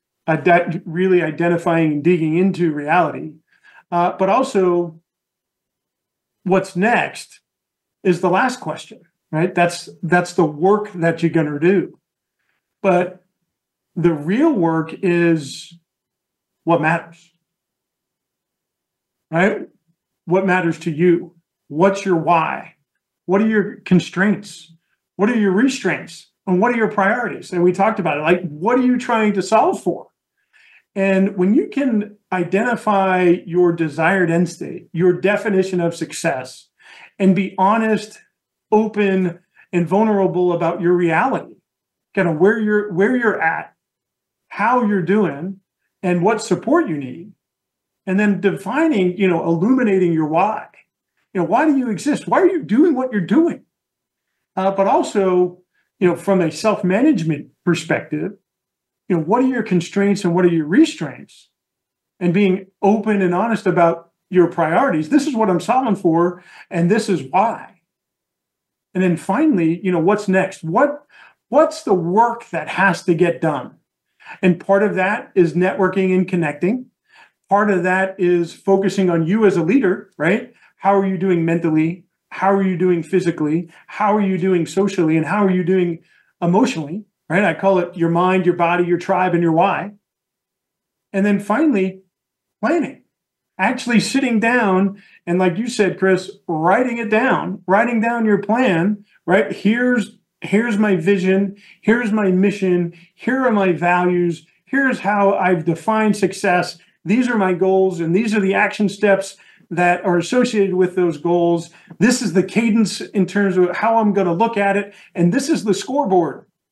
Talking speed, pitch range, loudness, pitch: 155 wpm, 175-210 Hz, -17 LUFS, 190 Hz